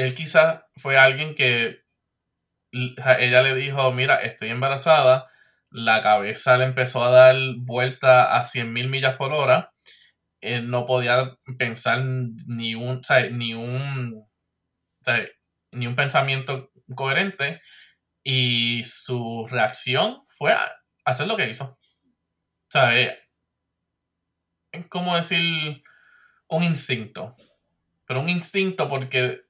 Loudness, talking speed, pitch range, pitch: -21 LUFS, 120 wpm, 115-135 Hz, 130 Hz